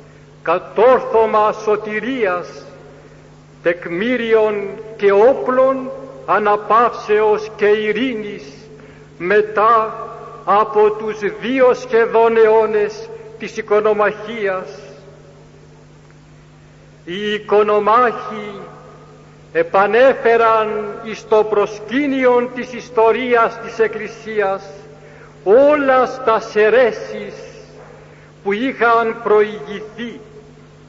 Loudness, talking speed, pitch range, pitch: -15 LUFS, 60 wpm, 200-230 Hz, 215 Hz